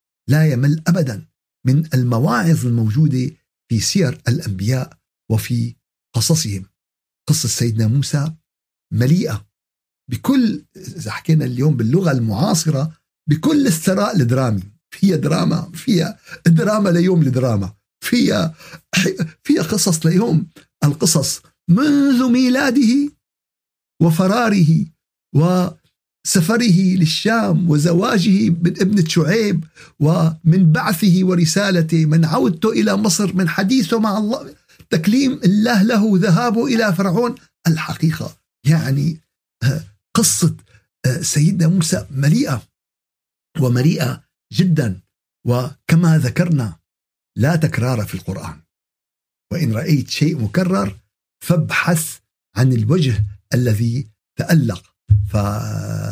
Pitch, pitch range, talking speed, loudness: 160 Hz, 120-185 Hz, 95 wpm, -17 LUFS